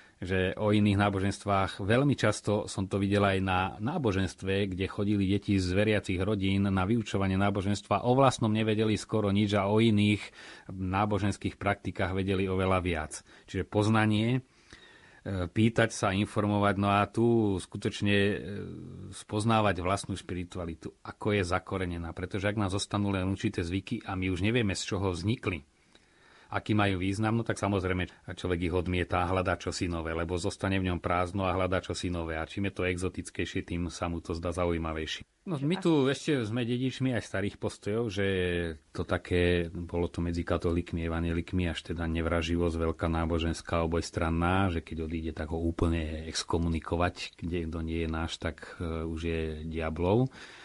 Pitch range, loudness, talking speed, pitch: 85-105 Hz, -30 LUFS, 160 wpm, 95 Hz